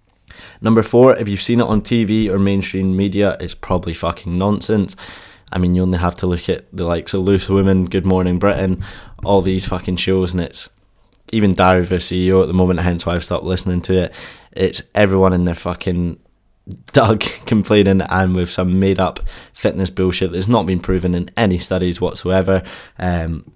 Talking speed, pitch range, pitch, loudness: 190 wpm, 90-100 Hz, 95 Hz, -17 LUFS